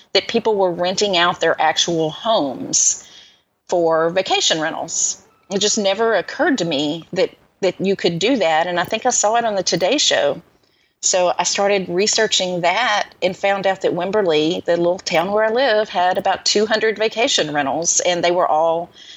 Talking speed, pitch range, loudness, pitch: 180 wpm, 175-215 Hz, -17 LUFS, 190 Hz